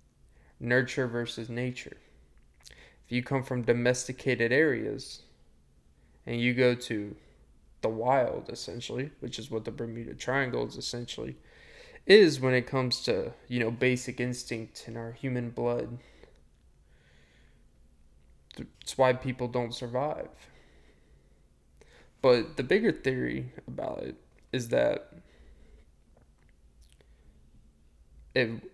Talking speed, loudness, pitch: 105 wpm, -29 LUFS, 115 Hz